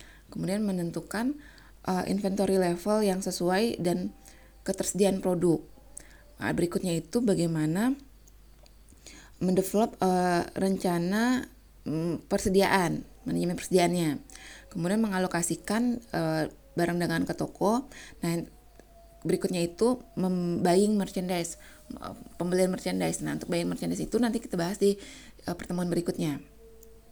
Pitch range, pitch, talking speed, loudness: 170-200 Hz, 185 Hz, 100 wpm, -29 LUFS